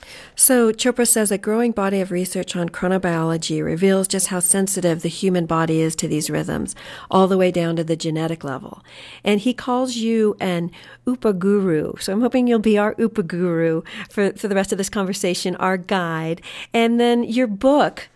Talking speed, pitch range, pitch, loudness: 190 wpm, 170-220 Hz, 190 Hz, -19 LUFS